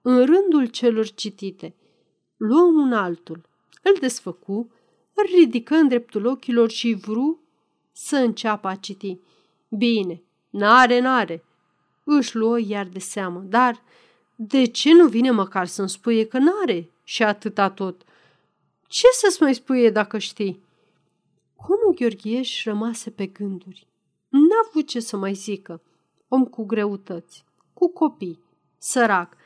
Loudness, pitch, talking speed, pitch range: -20 LUFS, 225 Hz, 130 wpm, 195-260 Hz